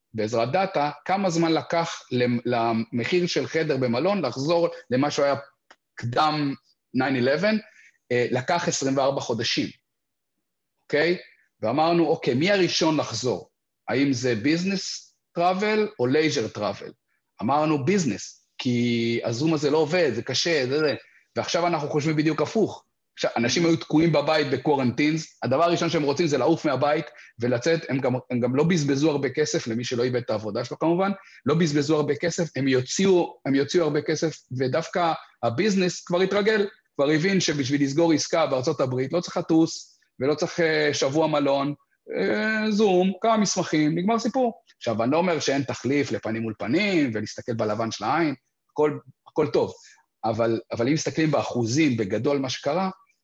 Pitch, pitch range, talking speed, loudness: 150 Hz, 130-175 Hz, 150 wpm, -24 LUFS